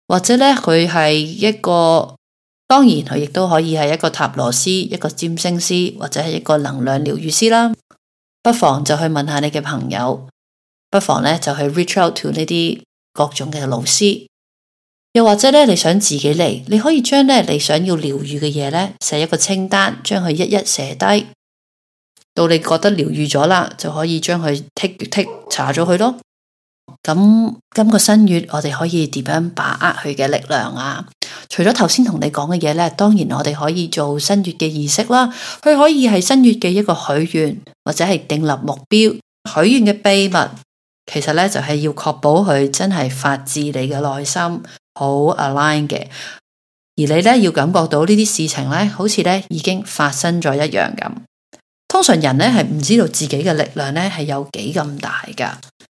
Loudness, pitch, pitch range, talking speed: -15 LUFS, 165 Hz, 145-200 Hz, 270 characters per minute